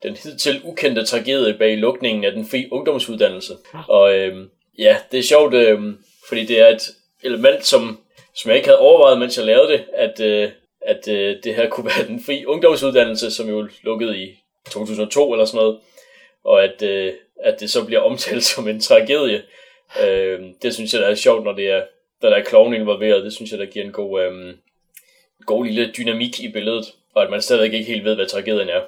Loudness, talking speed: -17 LUFS, 210 wpm